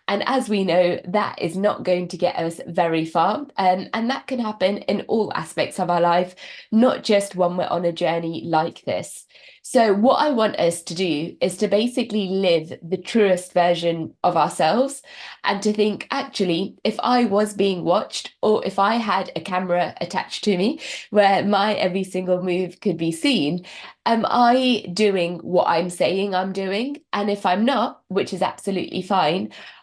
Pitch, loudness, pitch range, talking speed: 195 Hz, -21 LUFS, 180-215 Hz, 185 wpm